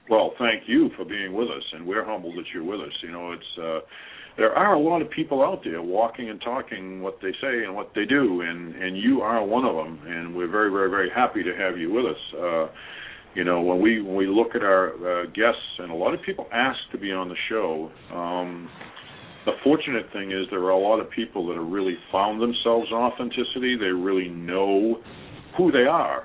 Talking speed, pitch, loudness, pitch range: 230 wpm, 95 Hz, -24 LUFS, 85-115 Hz